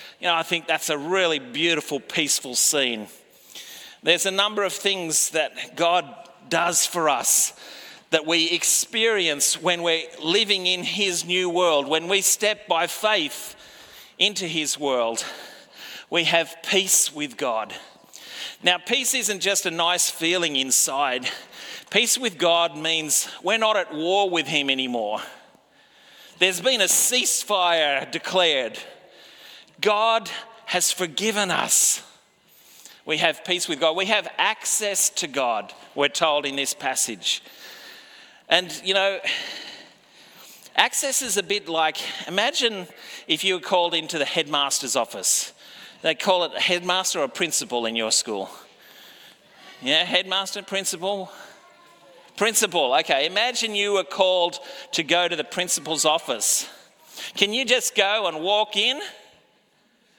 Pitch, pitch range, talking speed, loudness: 180 Hz, 160-205 Hz, 135 wpm, -21 LUFS